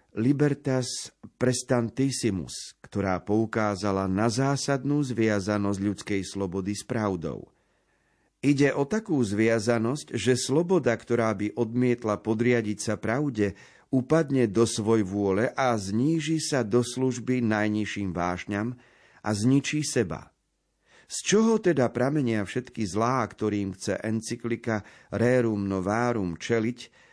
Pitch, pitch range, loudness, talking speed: 115 Hz, 105-130 Hz, -26 LUFS, 110 wpm